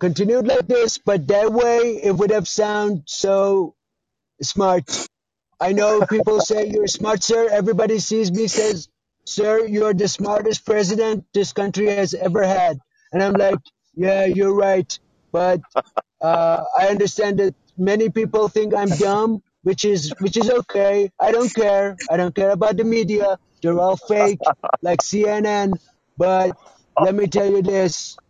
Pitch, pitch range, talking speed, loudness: 200 Hz, 190-215 Hz, 155 wpm, -19 LUFS